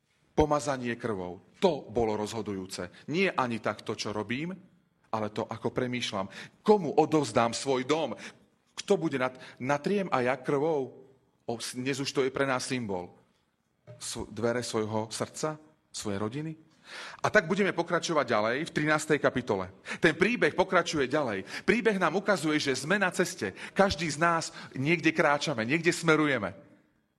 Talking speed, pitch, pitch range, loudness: 140 wpm, 140 Hz, 115-170 Hz, -29 LUFS